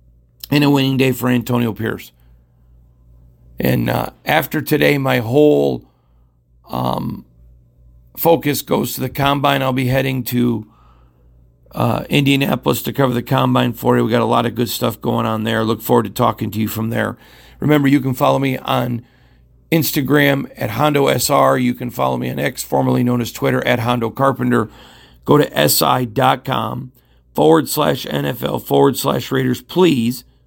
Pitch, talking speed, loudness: 120 Hz, 160 wpm, -16 LUFS